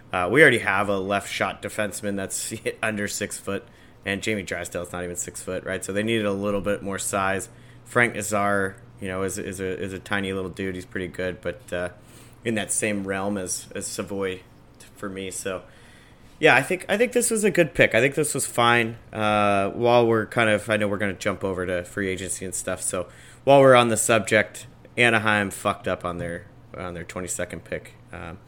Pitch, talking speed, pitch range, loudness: 105 Hz, 220 wpm, 95-120 Hz, -23 LUFS